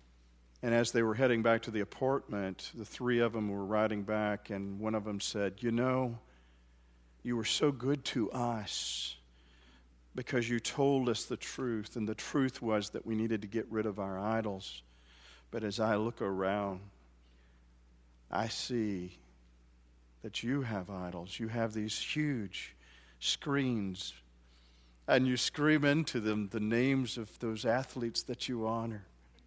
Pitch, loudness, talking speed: 105 Hz, -34 LUFS, 155 wpm